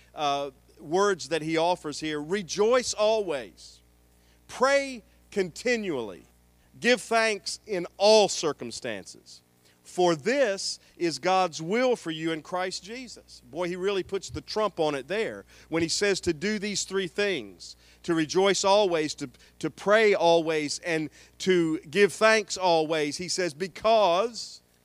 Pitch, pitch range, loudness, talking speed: 175 Hz, 150-205 Hz, -26 LUFS, 140 wpm